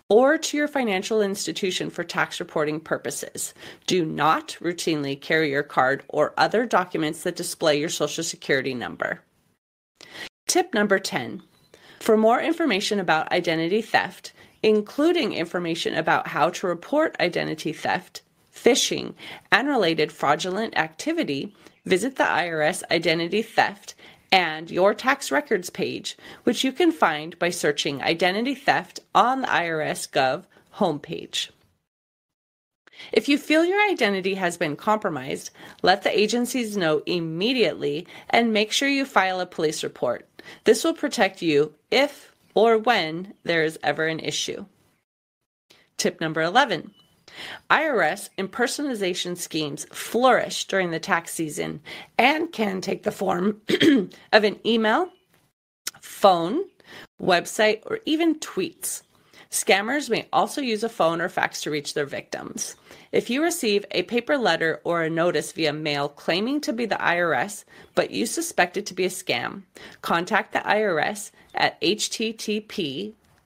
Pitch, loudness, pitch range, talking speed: 195 Hz, -23 LUFS, 165-245 Hz, 135 wpm